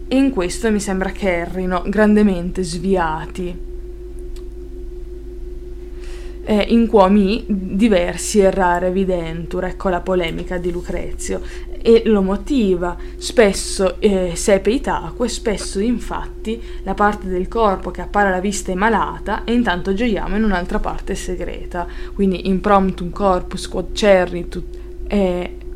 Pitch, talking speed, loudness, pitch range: 195 Hz, 125 wpm, -18 LUFS, 180-230 Hz